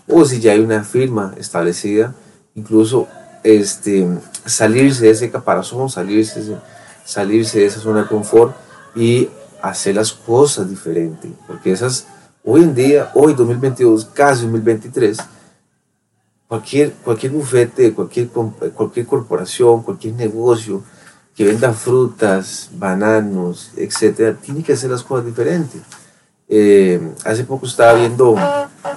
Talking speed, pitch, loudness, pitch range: 125 wpm, 115 Hz, -15 LUFS, 105-125 Hz